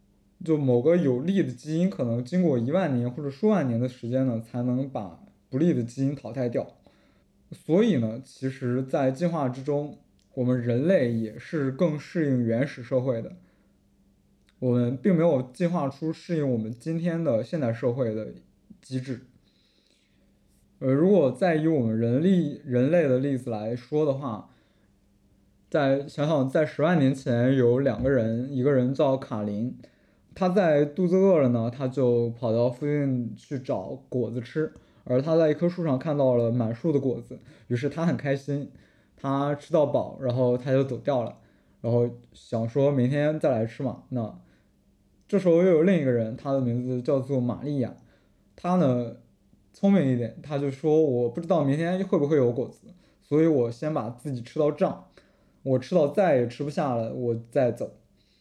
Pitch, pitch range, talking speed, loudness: 130 Hz, 120-155 Hz, 245 characters per minute, -26 LUFS